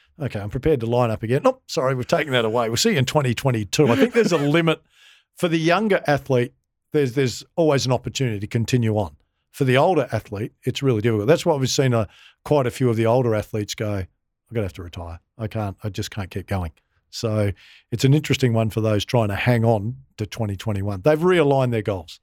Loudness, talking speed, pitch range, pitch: -21 LUFS, 230 wpm, 105-140 Hz, 120 Hz